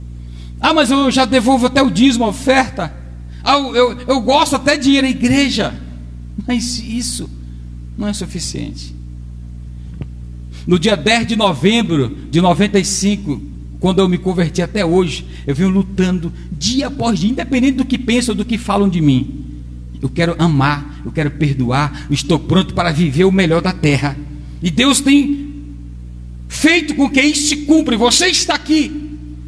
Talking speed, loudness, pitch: 165 wpm, -15 LUFS, 185 Hz